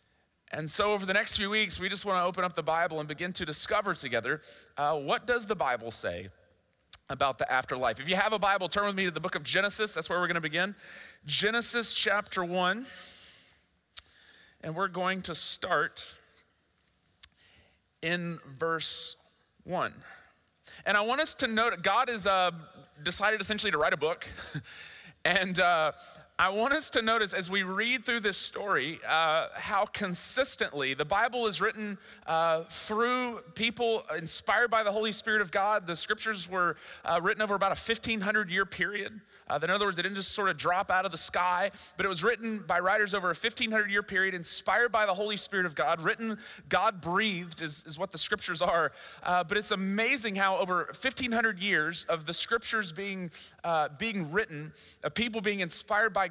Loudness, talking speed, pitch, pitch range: -29 LUFS, 190 wpm, 195 Hz, 165-215 Hz